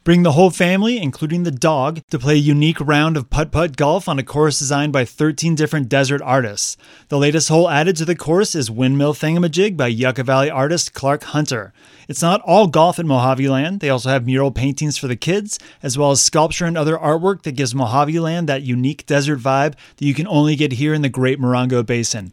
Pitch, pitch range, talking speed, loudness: 150 Hz, 135-160 Hz, 220 wpm, -17 LUFS